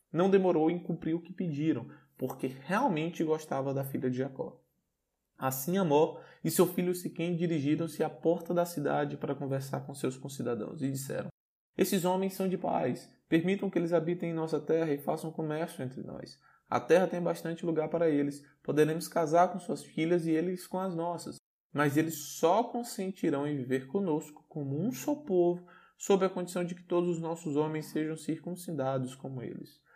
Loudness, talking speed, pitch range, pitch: -32 LUFS, 180 wpm, 150-180 Hz, 165 Hz